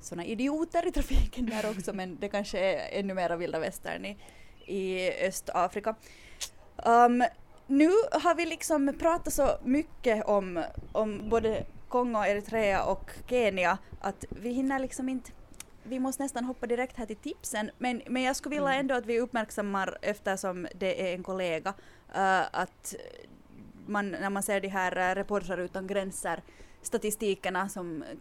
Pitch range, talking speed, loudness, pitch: 190-260 Hz, 155 wpm, -30 LUFS, 215 Hz